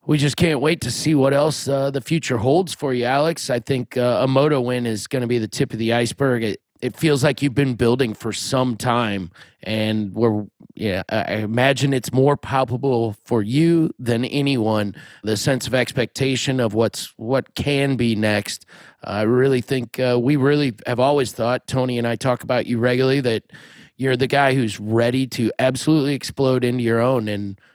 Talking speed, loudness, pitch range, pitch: 195 wpm, -20 LUFS, 115-140 Hz, 125 Hz